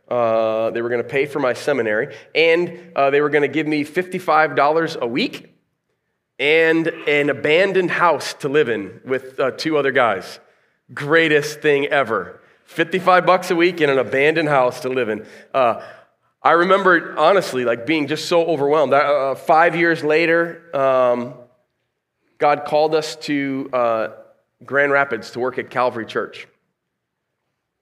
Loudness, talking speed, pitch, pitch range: -18 LUFS, 155 wpm, 150 Hz, 130-165 Hz